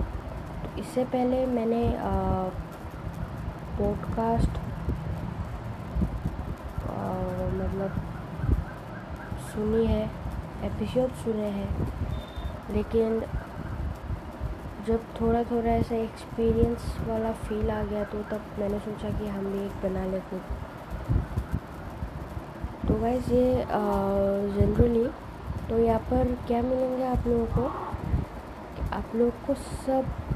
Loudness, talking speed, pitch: -29 LUFS, 95 wpm, 205 Hz